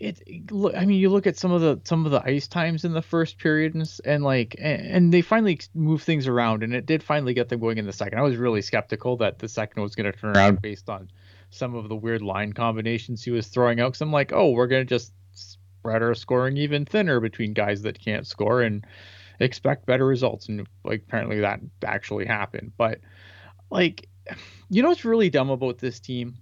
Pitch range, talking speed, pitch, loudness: 105-145 Hz, 225 wpm, 120 Hz, -24 LUFS